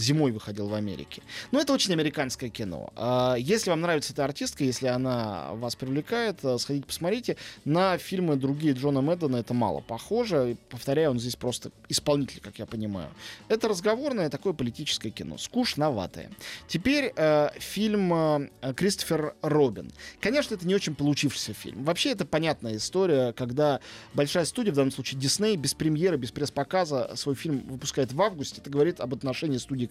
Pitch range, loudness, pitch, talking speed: 125-170 Hz, -28 LUFS, 140 Hz, 160 wpm